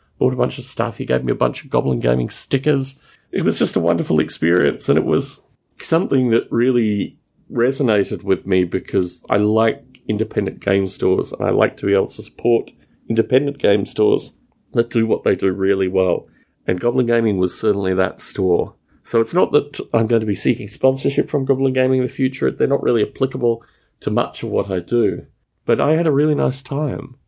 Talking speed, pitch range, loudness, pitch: 205 wpm, 100-130 Hz, -19 LUFS, 115 Hz